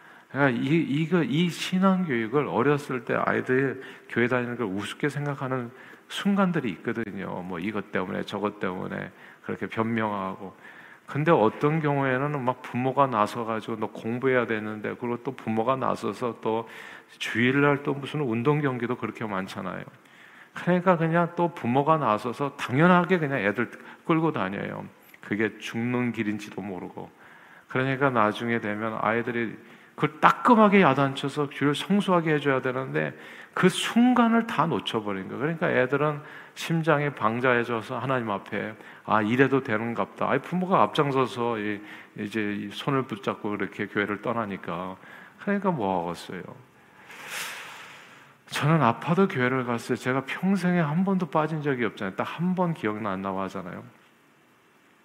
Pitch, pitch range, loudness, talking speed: 125 Hz, 110-150 Hz, -26 LUFS, 325 characters per minute